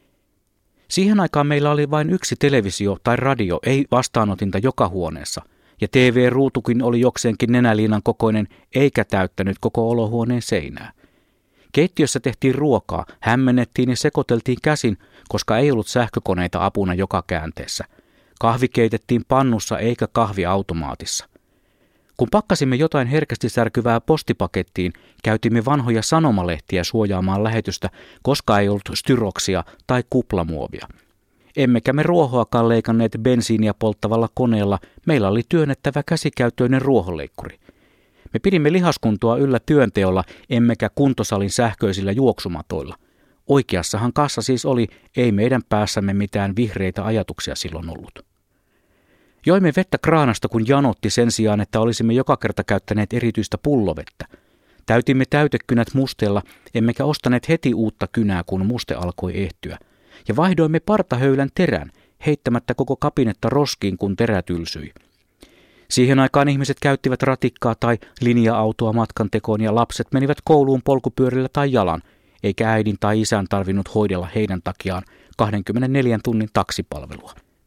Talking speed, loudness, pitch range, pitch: 120 wpm, -19 LUFS, 100-130 Hz, 115 Hz